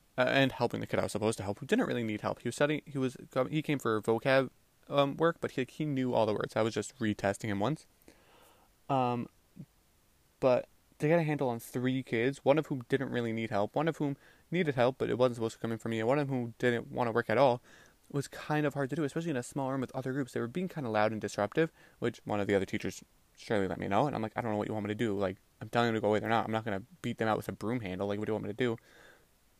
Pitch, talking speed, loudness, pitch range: 120 Hz, 305 wpm, -32 LUFS, 105-140 Hz